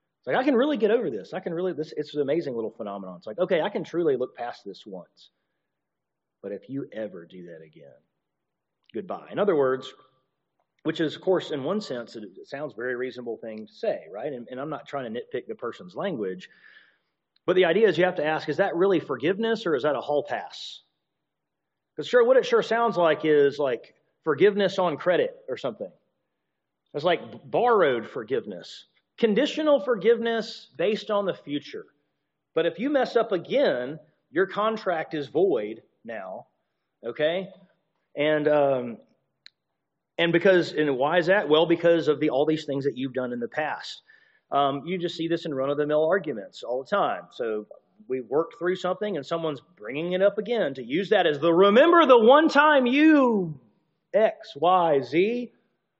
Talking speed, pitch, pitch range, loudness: 185 wpm, 180 Hz, 150-230 Hz, -24 LUFS